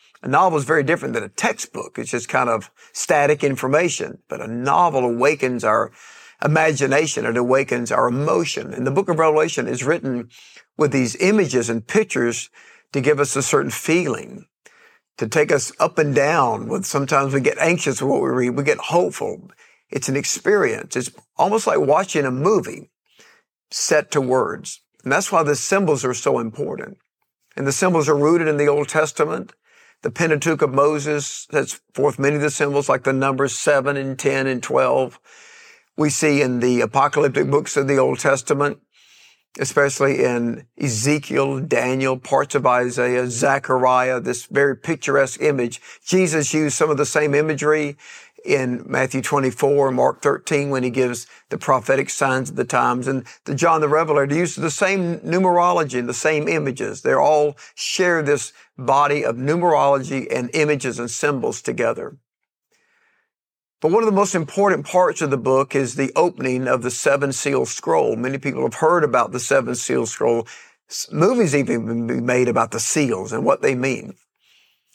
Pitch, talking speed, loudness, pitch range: 145 Hz, 170 wpm, -19 LUFS, 130-165 Hz